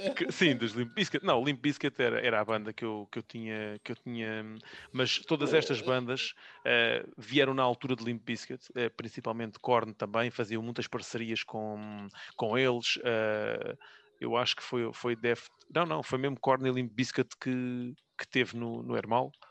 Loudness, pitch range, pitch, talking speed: -32 LUFS, 115-130 Hz, 120 Hz, 190 wpm